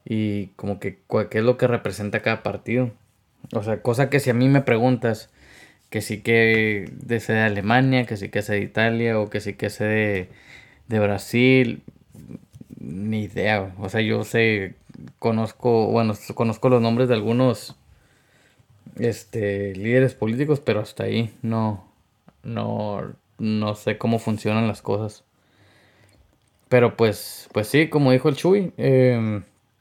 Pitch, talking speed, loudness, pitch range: 110 Hz, 155 wpm, -22 LUFS, 105-120 Hz